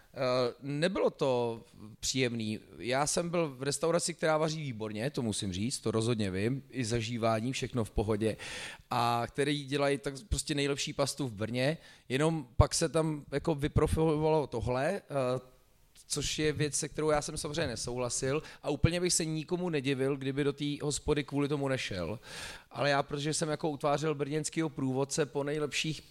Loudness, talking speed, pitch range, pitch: -32 LUFS, 160 wpm, 125-155 Hz, 140 Hz